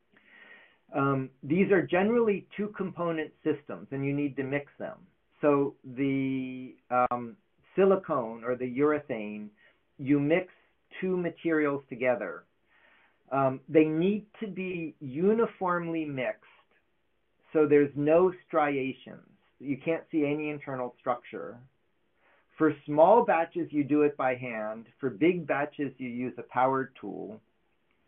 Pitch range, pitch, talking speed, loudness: 130-170 Hz, 145 Hz, 125 wpm, -29 LUFS